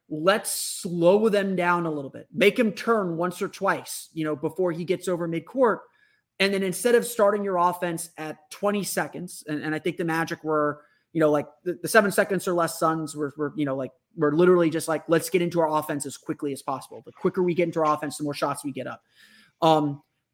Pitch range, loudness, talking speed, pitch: 155-190 Hz, -25 LUFS, 235 wpm, 170 Hz